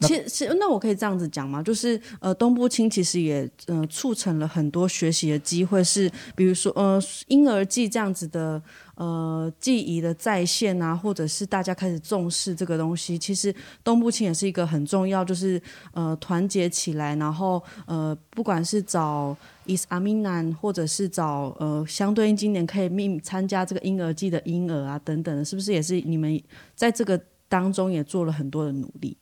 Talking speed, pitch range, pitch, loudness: 300 characters per minute, 160-200 Hz, 180 Hz, -25 LUFS